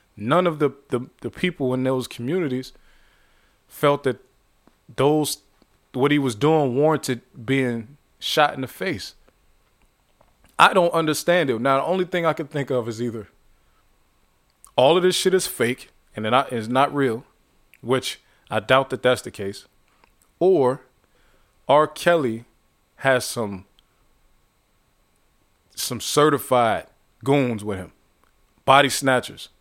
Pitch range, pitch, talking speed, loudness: 115-145 Hz, 130 Hz, 130 wpm, -21 LUFS